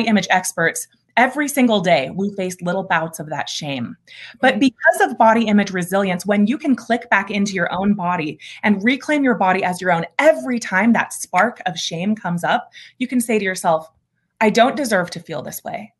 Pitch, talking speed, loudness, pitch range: 200 Hz, 205 wpm, -18 LUFS, 180-240 Hz